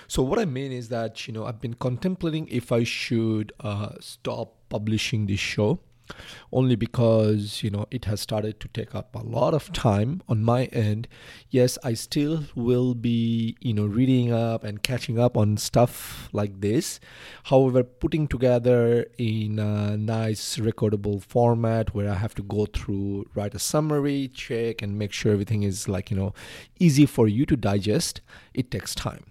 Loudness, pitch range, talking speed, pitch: -25 LUFS, 105-125 Hz, 175 wpm, 115 Hz